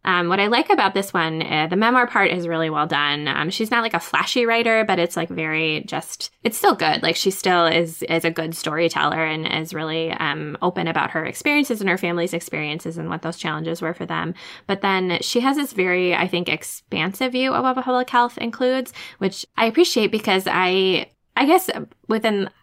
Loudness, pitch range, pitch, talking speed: -20 LUFS, 165-230 Hz, 180 Hz, 210 wpm